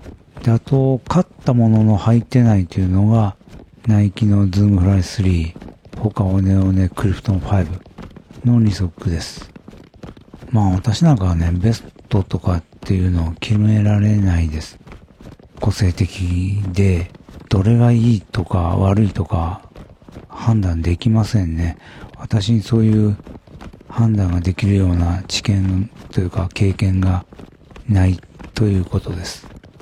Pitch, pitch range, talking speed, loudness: 100 Hz, 90-110 Hz, 250 characters per minute, -17 LUFS